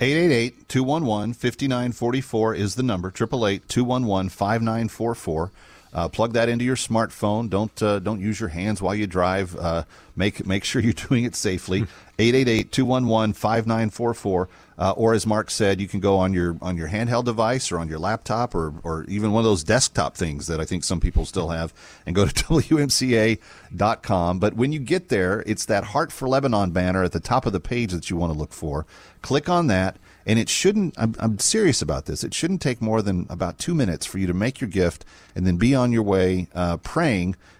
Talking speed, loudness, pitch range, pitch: 195 wpm, -23 LUFS, 95-120 Hz, 105 Hz